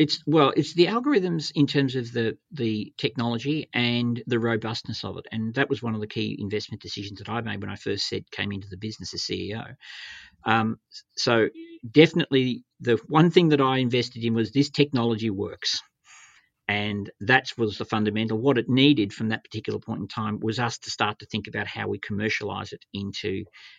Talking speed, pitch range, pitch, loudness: 195 wpm, 105-140 Hz, 115 Hz, -25 LUFS